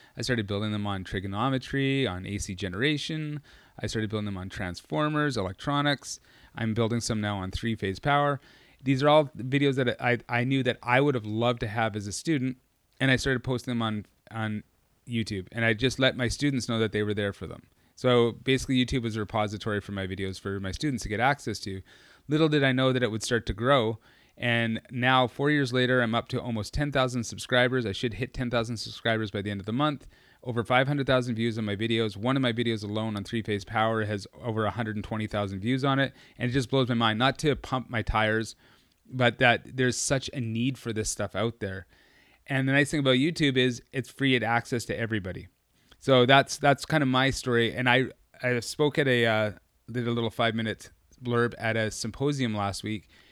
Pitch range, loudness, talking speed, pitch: 110-130 Hz, -27 LUFS, 215 wpm, 120 Hz